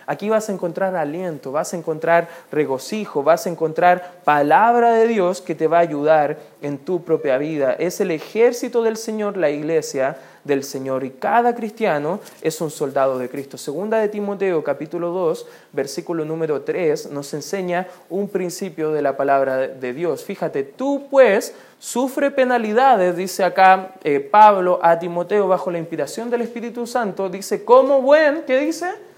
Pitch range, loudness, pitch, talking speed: 150-220 Hz, -19 LUFS, 180 Hz, 165 wpm